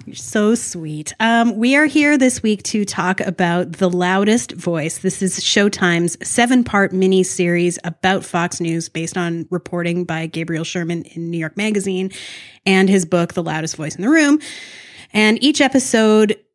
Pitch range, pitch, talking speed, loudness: 175-215 Hz, 190 Hz, 165 wpm, -17 LUFS